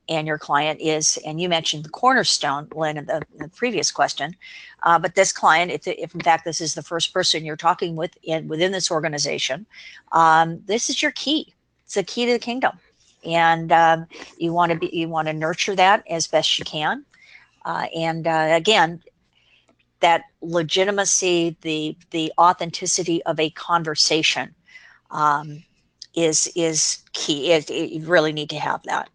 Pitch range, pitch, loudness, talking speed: 155-180 Hz, 165 Hz, -20 LUFS, 170 wpm